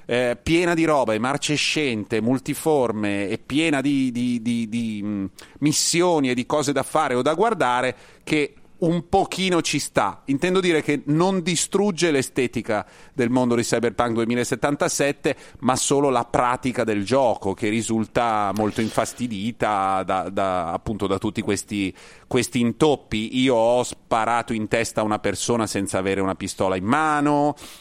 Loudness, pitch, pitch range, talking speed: -22 LUFS, 125 Hz, 110-145 Hz, 150 wpm